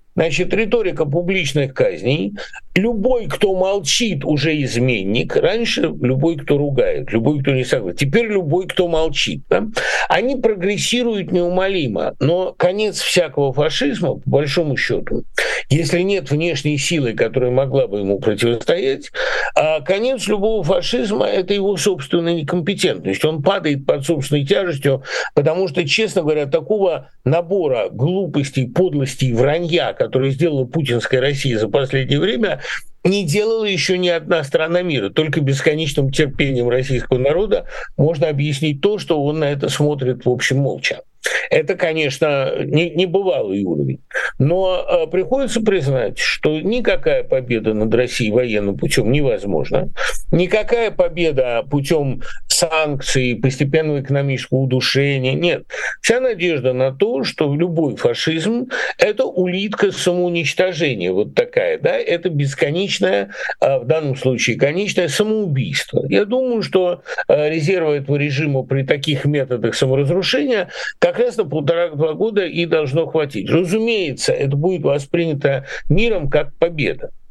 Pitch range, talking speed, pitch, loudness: 135-190 Hz, 125 wpm, 160 Hz, -18 LUFS